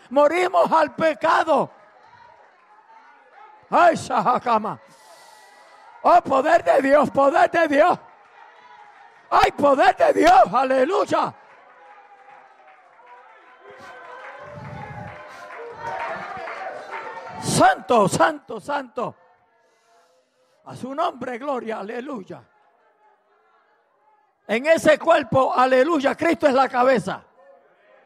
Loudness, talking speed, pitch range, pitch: -19 LUFS, 75 wpm, 255-365 Hz, 300 Hz